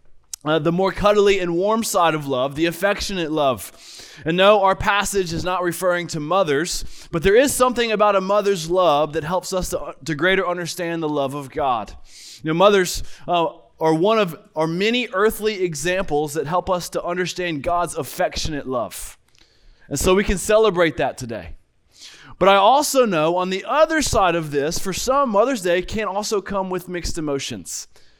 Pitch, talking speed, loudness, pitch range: 180 Hz, 185 wpm, -20 LUFS, 160-200 Hz